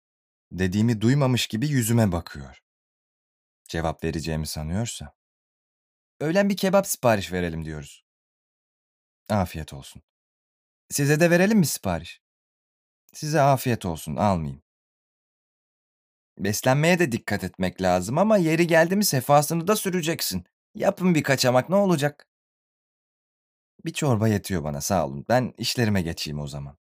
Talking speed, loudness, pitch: 120 wpm, -23 LUFS, 115 Hz